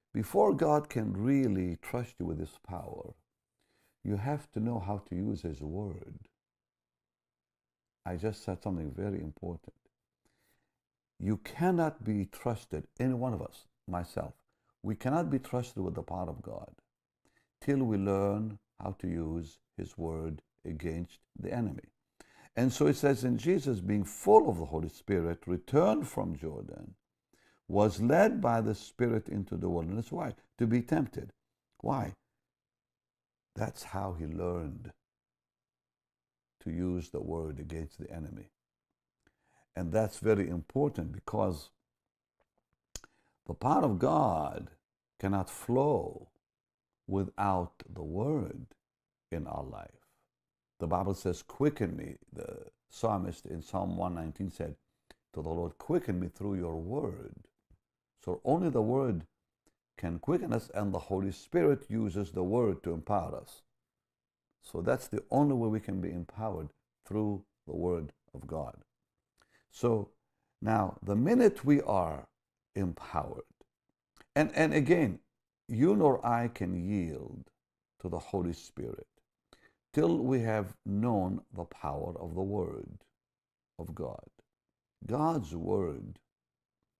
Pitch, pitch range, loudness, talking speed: 95 Hz, 80-110 Hz, -33 LUFS, 130 wpm